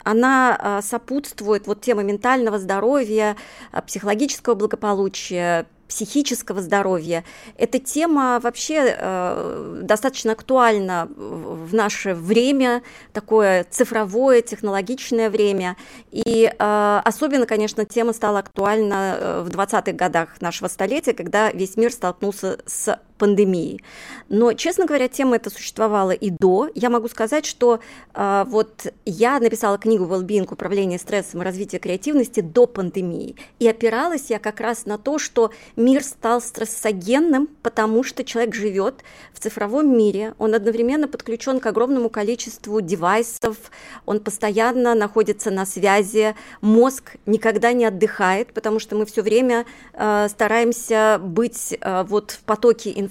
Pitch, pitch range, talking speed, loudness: 220 Hz, 205-235 Hz, 130 wpm, -20 LUFS